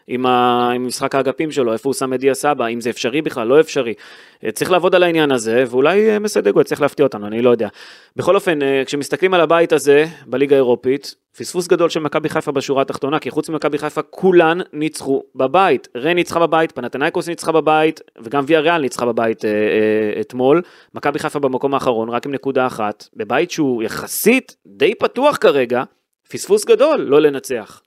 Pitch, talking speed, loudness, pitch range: 145 Hz, 175 wpm, -16 LUFS, 130-170 Hz